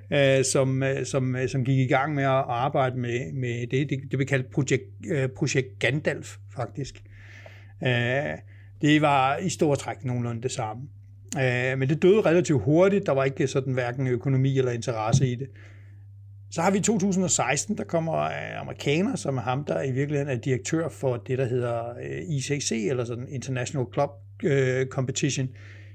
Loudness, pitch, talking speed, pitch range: -25 LUFS, 130 Hz, 175 wpm, 120-140 Hz